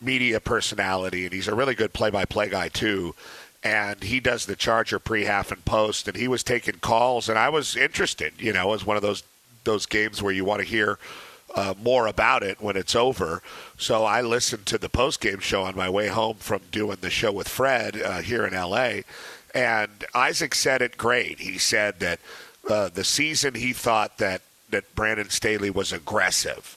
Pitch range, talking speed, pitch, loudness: 100-115 Hz, 195 wpm, 105 Hz, -24 LUFS